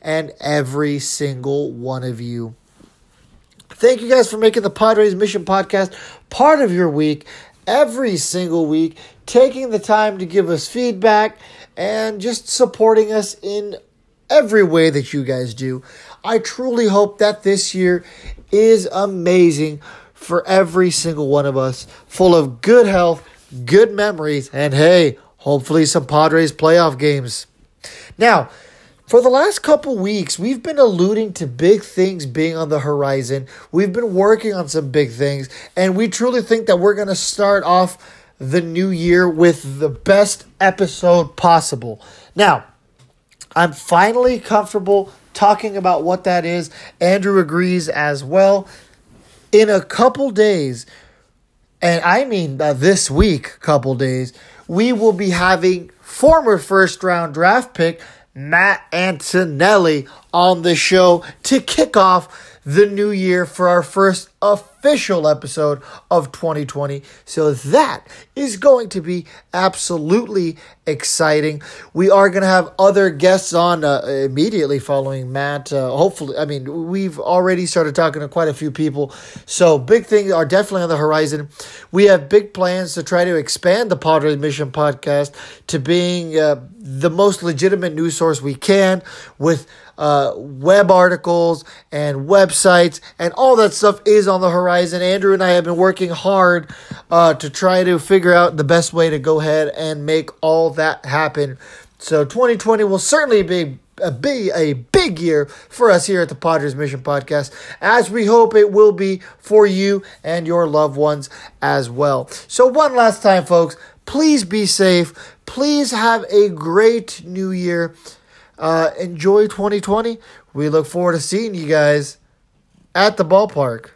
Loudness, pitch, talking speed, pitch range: -15 LUFS, 175 Hz, 155 wpm, 150-200 Hz